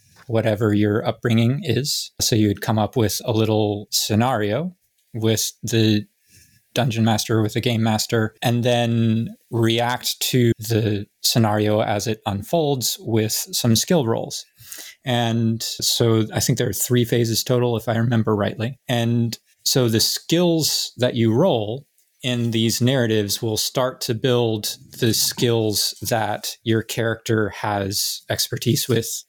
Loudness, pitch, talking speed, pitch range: -20 LUFS, 115 Hz, 140 wpm, 110-120 Hz